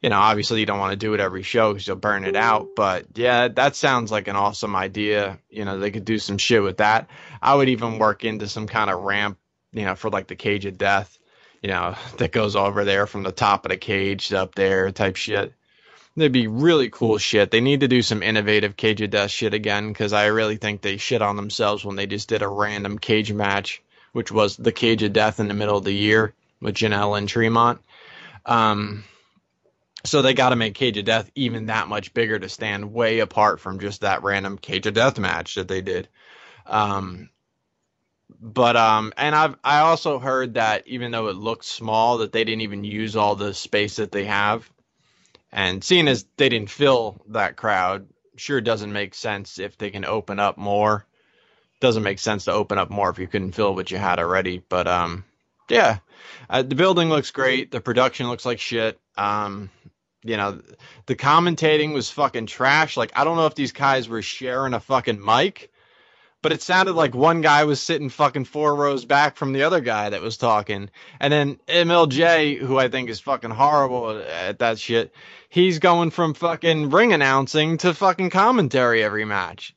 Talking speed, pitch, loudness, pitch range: 210 wpm, 110 Hz, -21 LUFS, 100-135 Hz